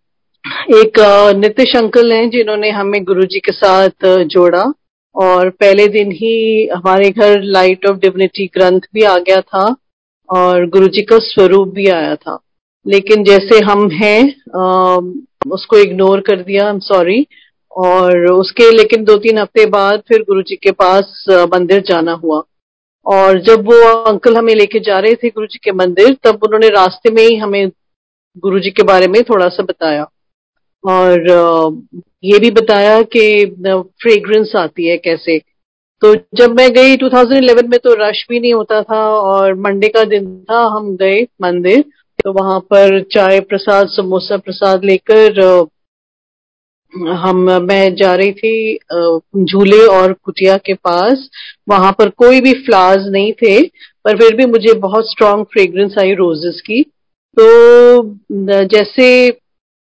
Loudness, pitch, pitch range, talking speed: -9 LUFS, 200 Hz, 190-225 Hz, 145 wpm